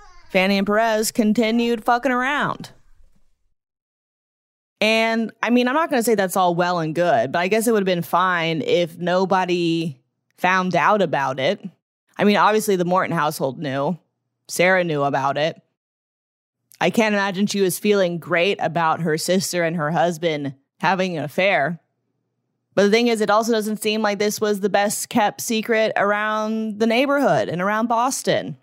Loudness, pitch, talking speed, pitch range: -20 LUFS, 190 Hz, 170 wpm, 170-220 Hz